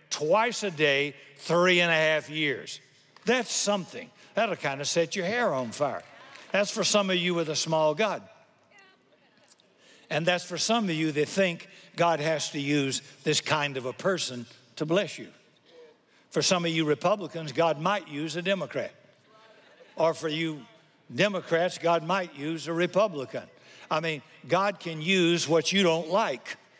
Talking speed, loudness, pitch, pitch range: 170 wpm, -27 LUFS, 165 Hz, 155-190 Hz